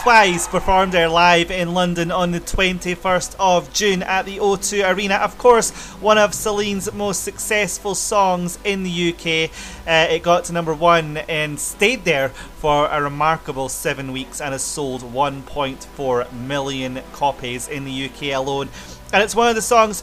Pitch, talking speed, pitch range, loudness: 170 Hz, 170 wpm, 145-195 Hz, -18 LUFS